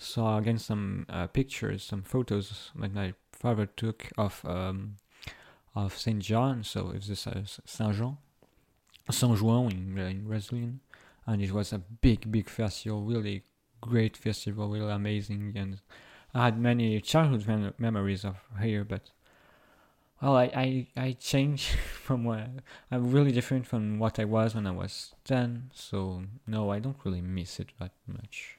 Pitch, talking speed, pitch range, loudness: 110 Hz, 165 wpm, 100-120 Hz, -31 LUFS